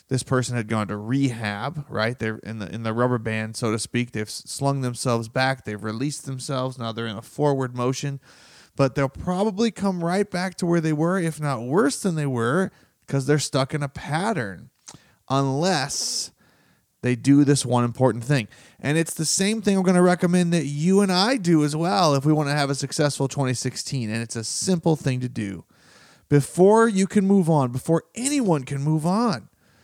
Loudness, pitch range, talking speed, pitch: -23 LUFS, 125-170 Hz, 200 wpm, 140 Hz